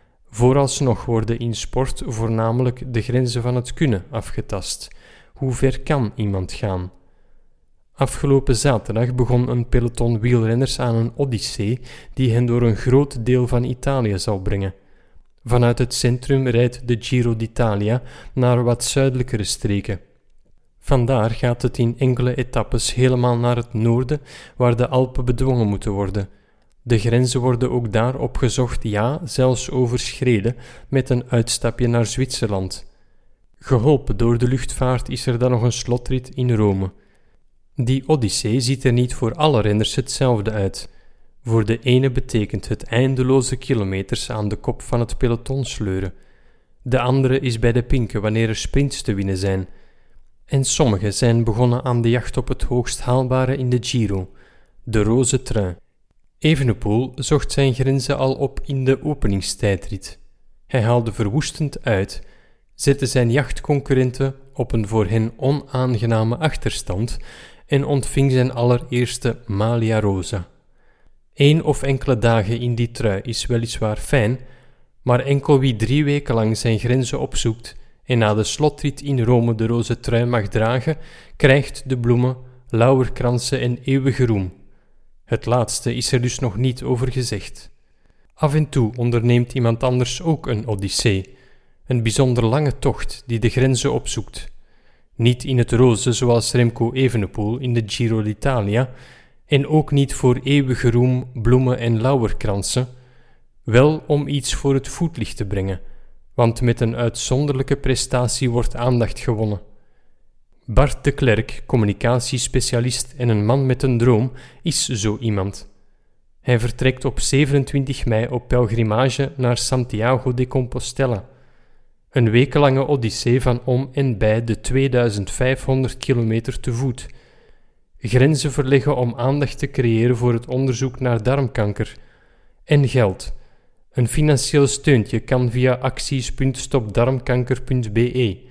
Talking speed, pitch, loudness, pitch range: 140 wpm, 125 Hz, -19 LUFS, 115-130 Hz